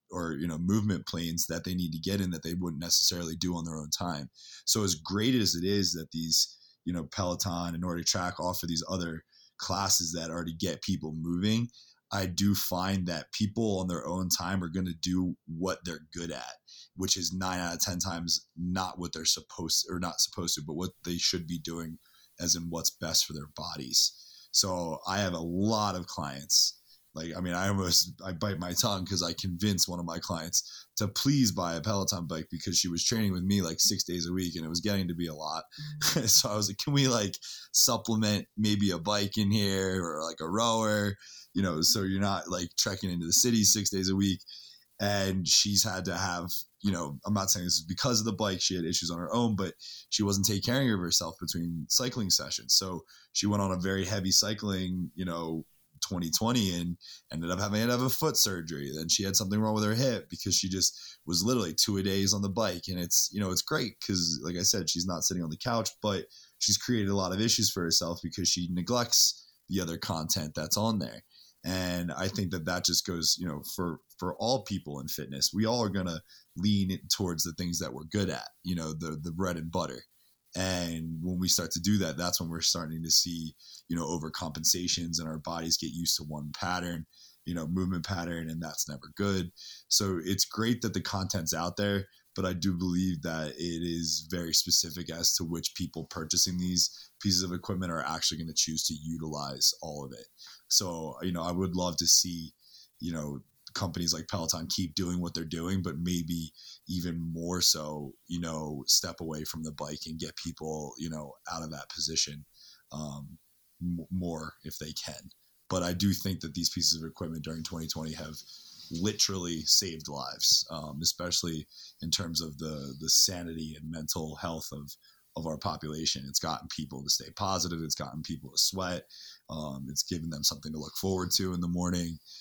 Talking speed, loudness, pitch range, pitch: 215 wpm, -29 LUFS, 80-95 Hz, 90 Hz